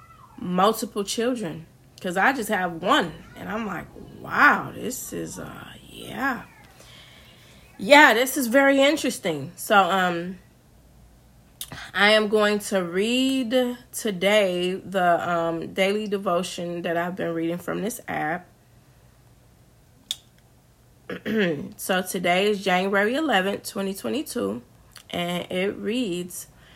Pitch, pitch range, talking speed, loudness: 190 Hz, 170-215 Hz, 110 wpm, -23 LUFS